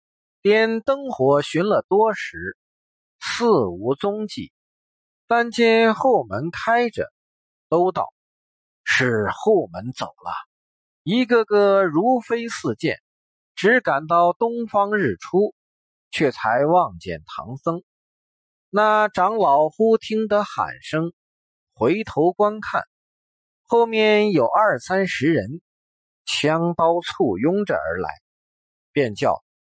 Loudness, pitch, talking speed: -20 LUFS, 190 Hz, 145 characters per minute